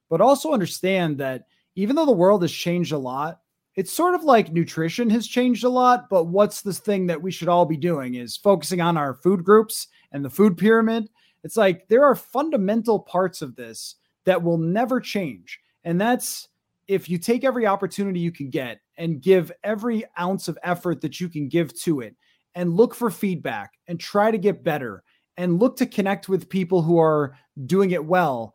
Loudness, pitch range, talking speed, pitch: -22 LUFS, 170-215 Hz, 200 wpm, 185 Hz